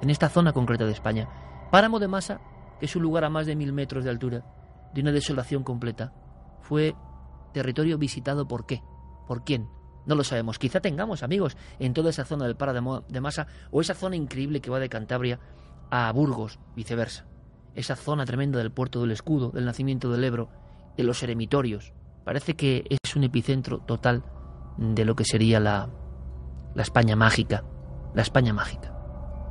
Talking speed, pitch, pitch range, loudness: 175 wpm, 125 Hz, 105-140 Hz, -27 LUFS